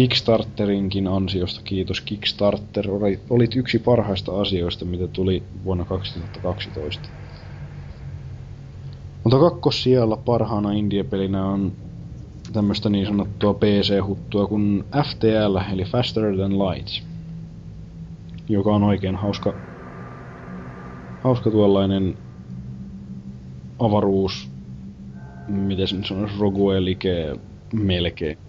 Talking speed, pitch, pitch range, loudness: 85 wpm, 100 Hz, 90-105 Hz, -22 LUFS